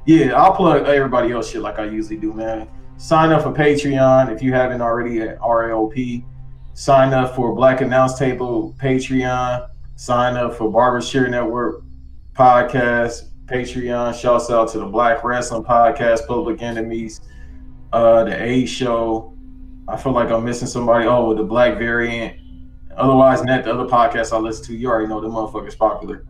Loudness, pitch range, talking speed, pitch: -17 LUFS, 110-130 Hz, 170 wpm, 120 Hz